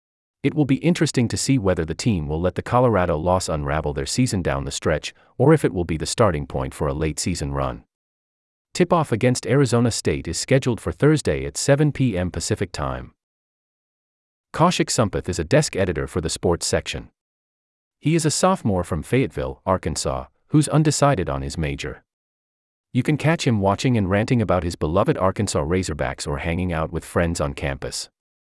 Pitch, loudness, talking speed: 90 Hz, -21 LUFS, 180 wpm